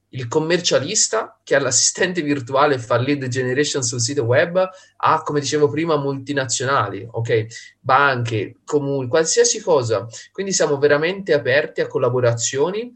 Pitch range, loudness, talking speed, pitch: 125-160 Hz, -19 LUFS, 135 wpm, 145 Hz